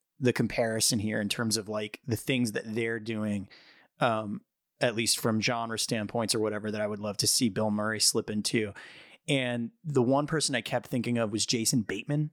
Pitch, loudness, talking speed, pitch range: 115 Hz, -29 LUFS, 200 wpm, 110-125 Hz